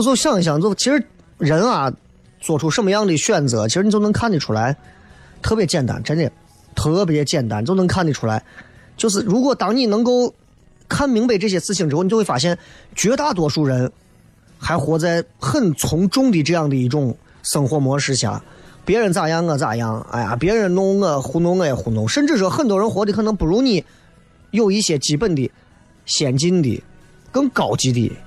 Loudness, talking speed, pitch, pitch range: -18 LUFS, 285 characters per minute, 165 Hz, 135-205 Hz